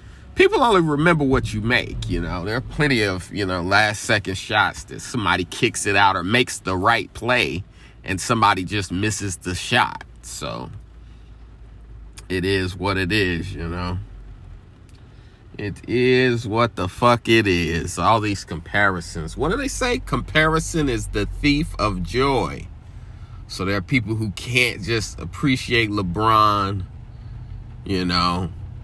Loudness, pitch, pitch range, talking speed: -20 LUFS, 105 Hz, 95-115 Hz, 150 wpm